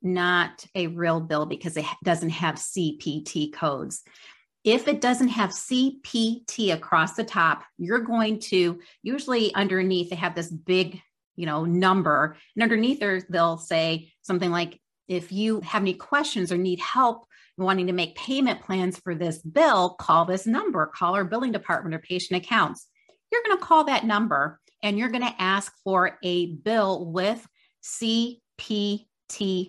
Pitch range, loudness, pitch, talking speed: 175-225 Hz, -25 LUFS, 185 Hz, 160 wpm